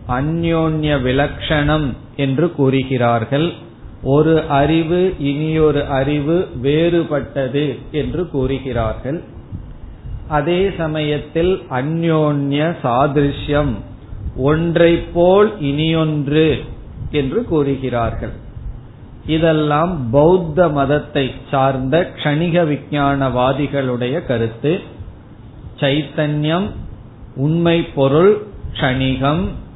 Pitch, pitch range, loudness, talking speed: 145 Hz, 130-160 Hz, -17 LUFS, 65 wpm